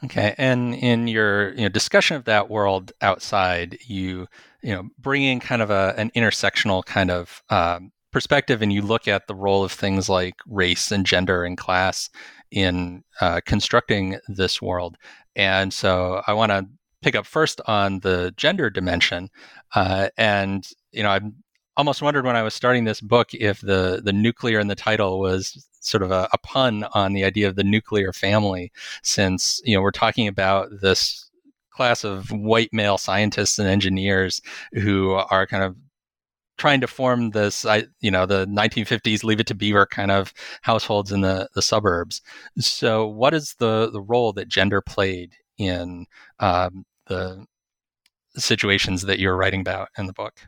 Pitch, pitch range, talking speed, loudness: 100 Hz, 95-115 Hz, 175 wpm, -21 LUFS